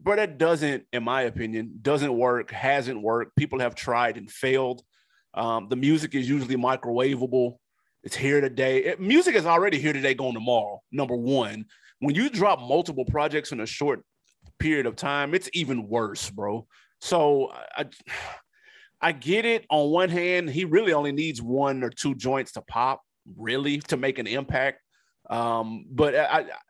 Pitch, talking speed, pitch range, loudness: 135 Hz, 170 wpm, 120-150 Hz, -25 LUFS